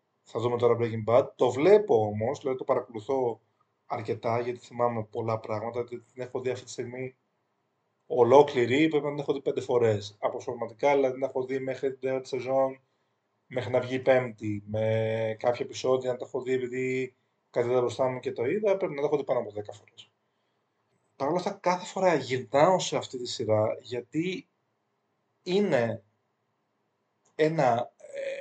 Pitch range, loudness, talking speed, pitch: 120-140 Hz, -28 LUFS, 175 wpm, 130 Hz